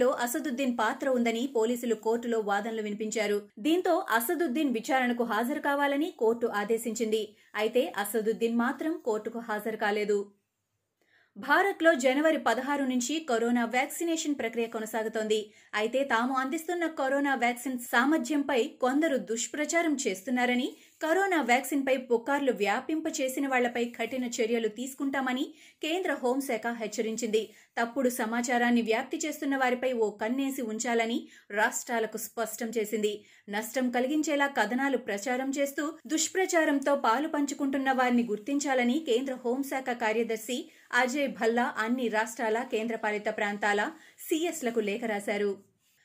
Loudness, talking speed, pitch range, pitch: -29 LUFS, 110 wpm, 225-280 Hz, 245 Hz